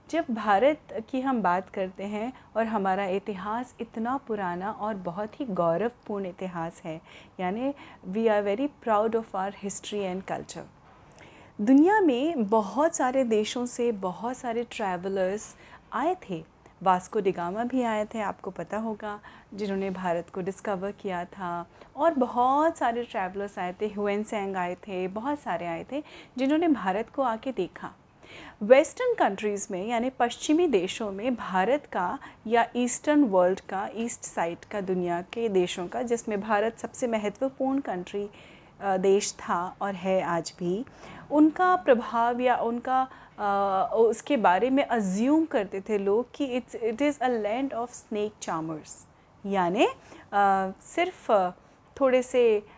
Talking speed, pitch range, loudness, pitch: 145 wpm, 190-250 Hz, -27 LUFS, 215 Hz